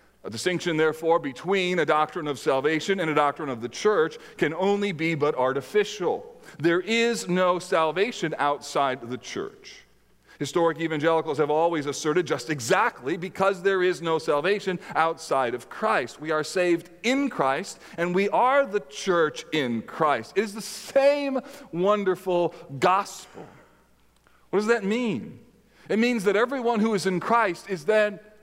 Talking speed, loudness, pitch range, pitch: 155 wpm, -25 LUFS, 160-215 Hz, 185 Hz